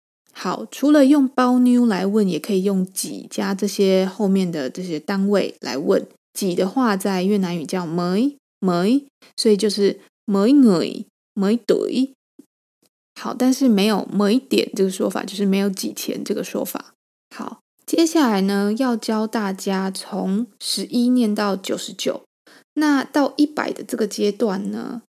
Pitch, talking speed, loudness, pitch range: 210 Hz, 215 characters per minute, -20 LUFS, 195-250 Hz